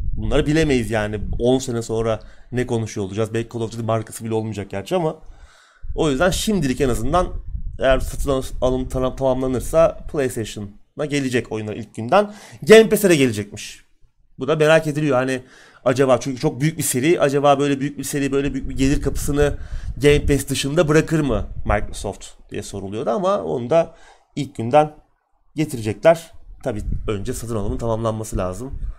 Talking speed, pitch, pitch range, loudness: 160 wpm, 130 Hz, 110-145 Hz, -20 LUFS